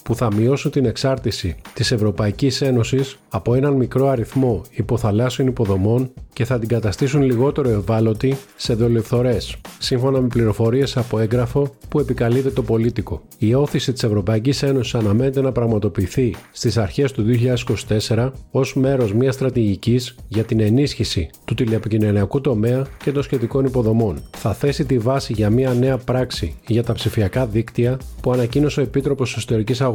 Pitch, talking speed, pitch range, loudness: 120 Hz, 150 wpm, 110-135 Hz, -19 LUFS